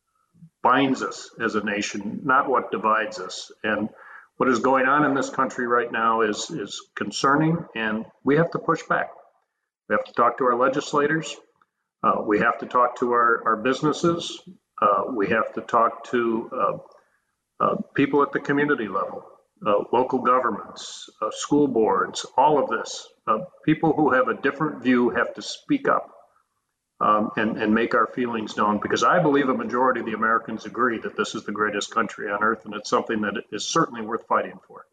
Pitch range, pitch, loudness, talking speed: 115-160 Hz, 130 Hz, -23 LUFS, 190 wpm